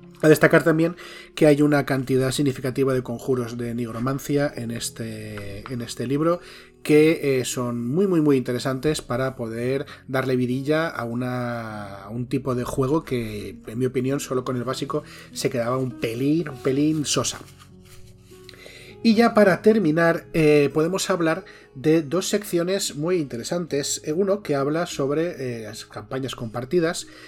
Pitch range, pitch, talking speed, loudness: 120-155 Hz, 135 Hz, 155 wpm, -23 LUFS